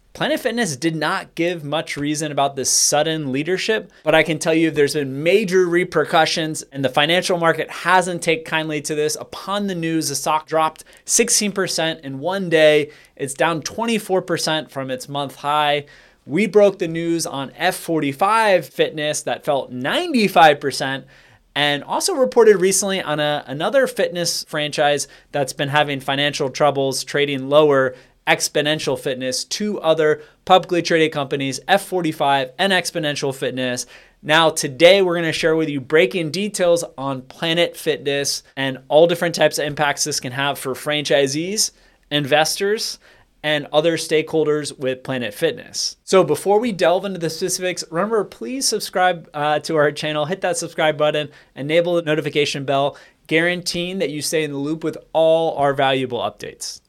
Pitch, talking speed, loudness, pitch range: 155 Hz, 155 wpm, -19 LUFS, 145-180 Hz